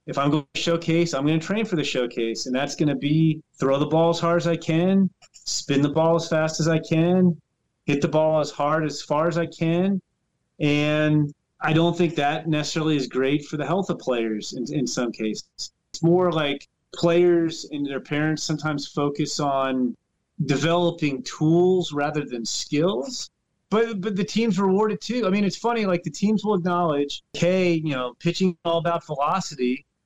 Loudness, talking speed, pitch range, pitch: -23 LUFS, 195 wpm, 145-175 Hz, 160 Hz